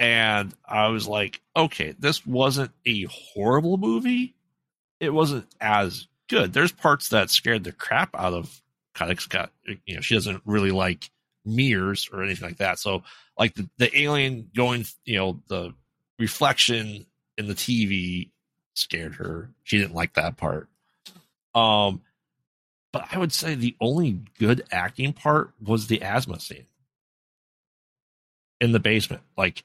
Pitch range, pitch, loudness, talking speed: 100-130 Hz, 110 Hz, -24 LUFS, 150 wpm